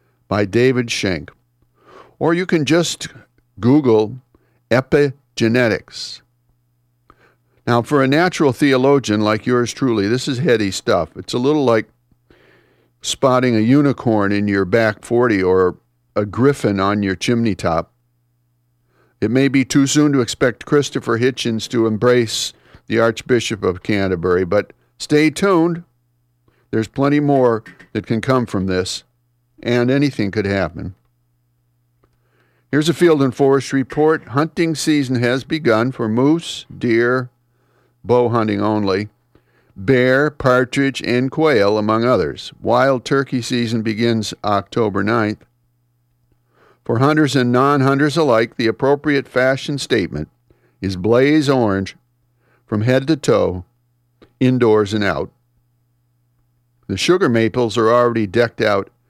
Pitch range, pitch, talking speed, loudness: 100-135 Hz, 120 Hz, 125 wpm, -17 LUFS